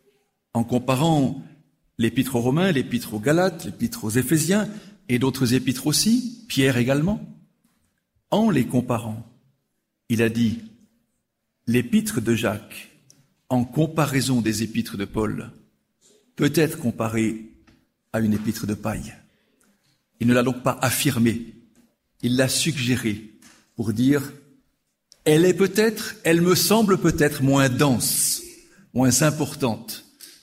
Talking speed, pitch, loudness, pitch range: 120 wpm, 130 Hz, -22 LUFS, 115-165 Hz